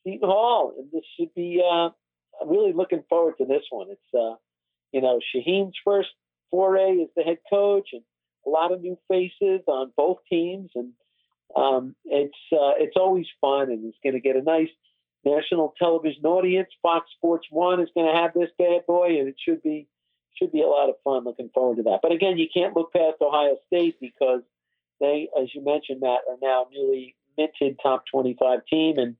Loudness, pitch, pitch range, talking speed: -23 LUFS, 160 Hz, 130-180 Hz, 195 wpm